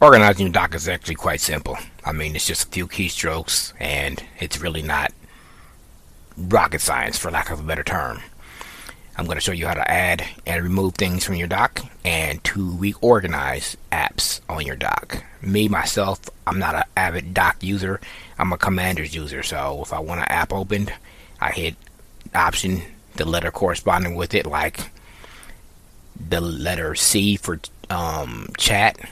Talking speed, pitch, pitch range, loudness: 165 wpm, 90 Hz, 80-95 Hz, -21 LUFS